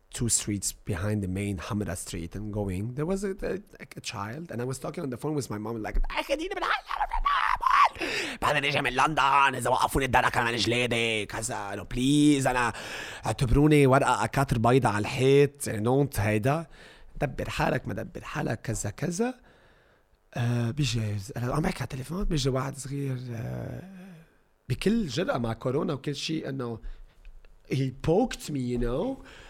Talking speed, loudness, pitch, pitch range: 165 wpm, -27 LUFS, 130 Hz, 110-150 Hz